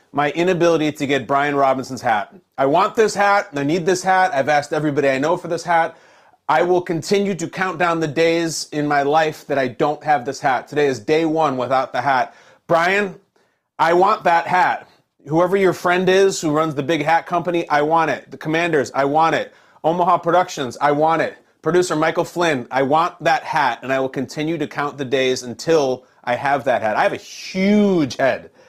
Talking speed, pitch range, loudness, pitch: 210 wpm, 145-175 Hz, -18 LUFS, 160 Hz